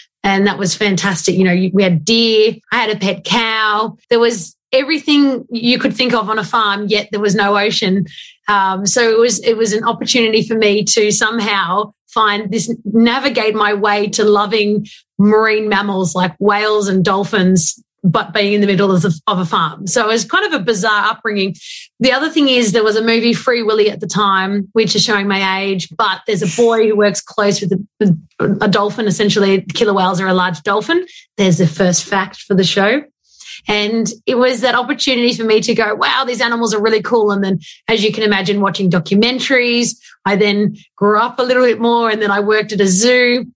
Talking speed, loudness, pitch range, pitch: 210 wpm, -14 LUFS, 195-230 Hz, 210 Hz